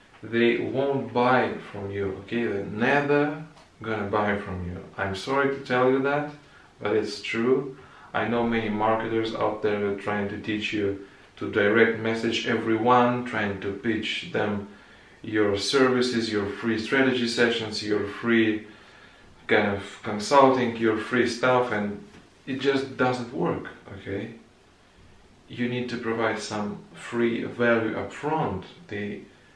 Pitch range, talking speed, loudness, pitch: 105-125 Hz, 140 wpm, -25 LUFS, 115 Hz